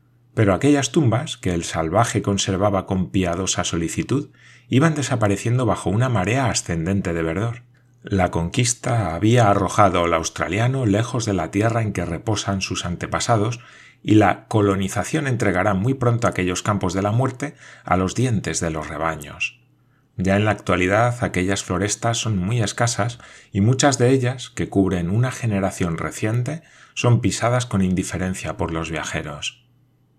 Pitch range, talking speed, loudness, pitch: 95-120 Hz, 150 wpm, -21 LUFS, 105 Hz